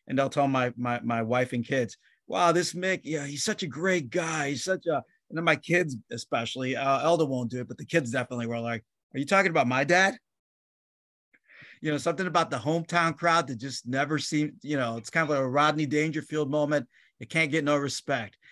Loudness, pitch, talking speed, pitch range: -27 LUFS, 150 Hz, 225 wpm, 130-165 Hz